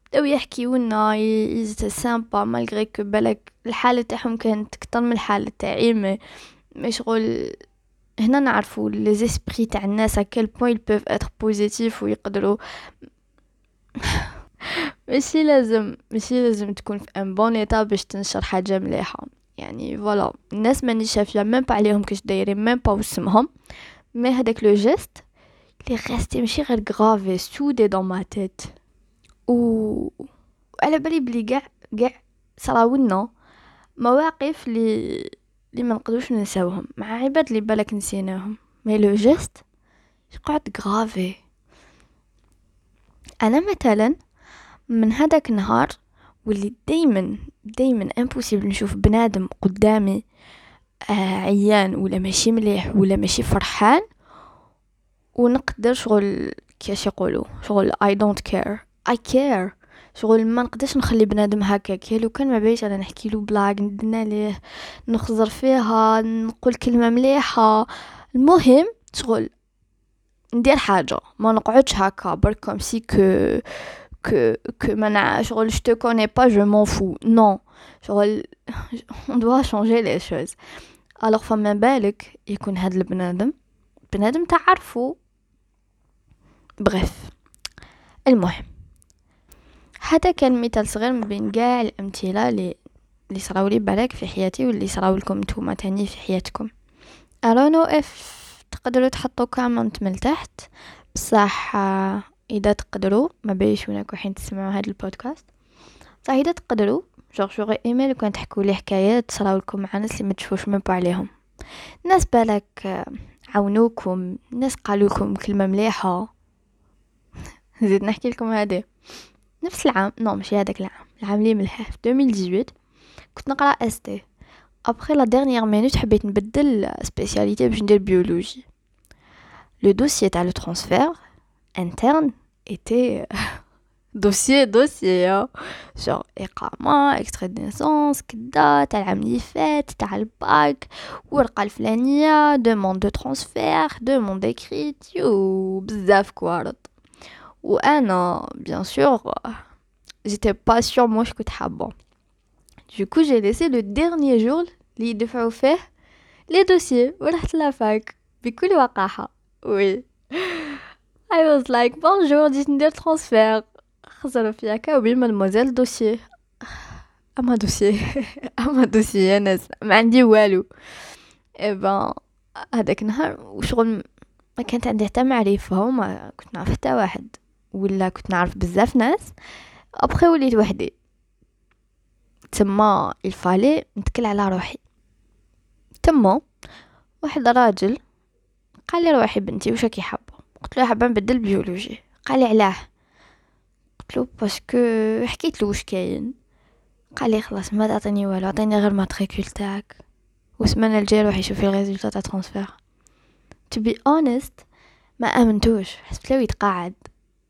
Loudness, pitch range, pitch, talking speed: -20 LUFS, 200-250 Hz, 220 Hz, 120 wpm